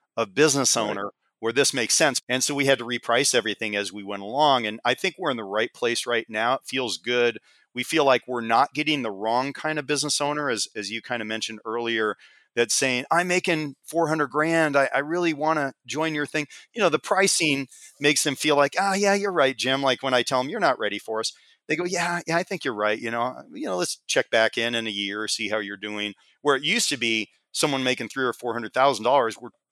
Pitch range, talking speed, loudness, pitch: 115-150 Hz, 255 wpm, -24 LUFS, 130 Hz